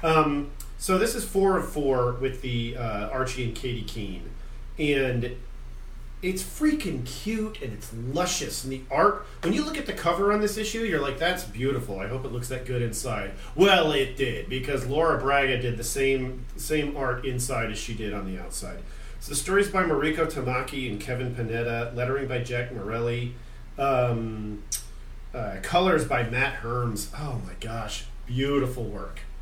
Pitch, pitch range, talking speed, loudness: 125 Hz, 115-140 Hz, 175 wpm, -27 LUFS